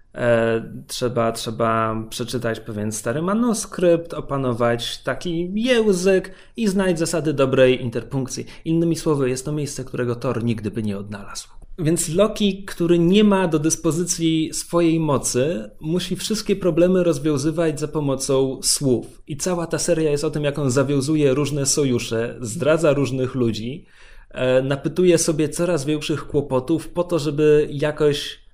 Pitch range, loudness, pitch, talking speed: 125-170 Hz, -21 LUFS, 150 Hz, 135 wpm